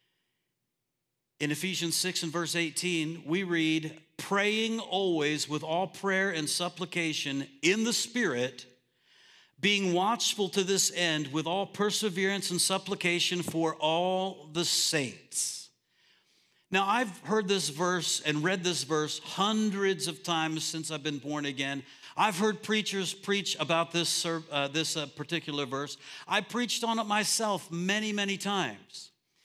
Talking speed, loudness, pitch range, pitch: 140 wpm, -29 LUFS, 155-195 Hz, 175 Hz